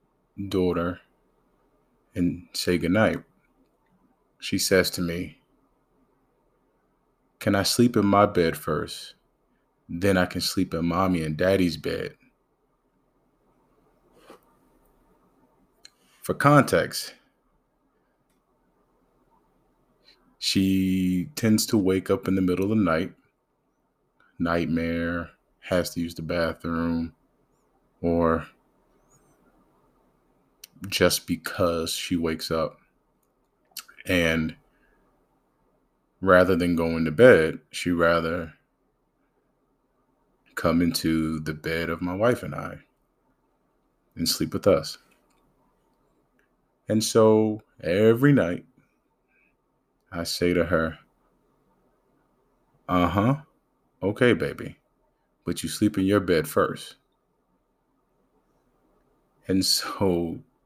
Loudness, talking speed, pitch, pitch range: -24 LUFS, 90 wpm, 85 Hz, 85-95 Hz